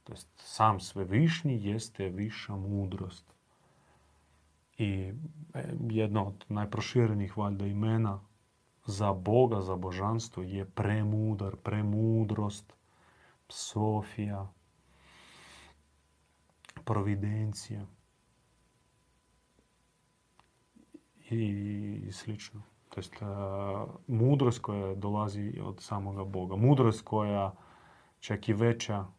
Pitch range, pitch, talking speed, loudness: 95-110 Hz, 105 Hz, 75 wpm, -32 LUFS